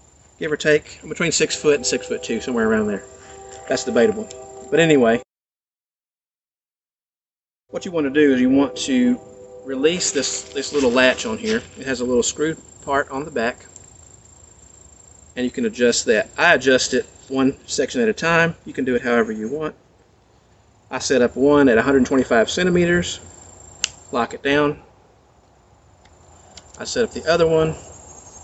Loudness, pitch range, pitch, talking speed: -19 LUFS, 105-155 Hz, 130 Hz, 165 wpm